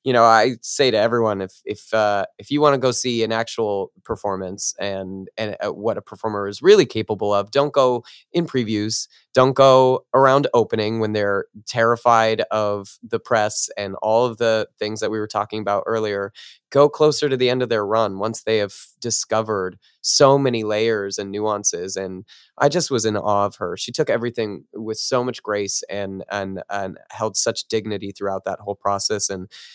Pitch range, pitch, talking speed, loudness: 100-120 Hz, 110 Hz, 195 wpm, -20 LUFS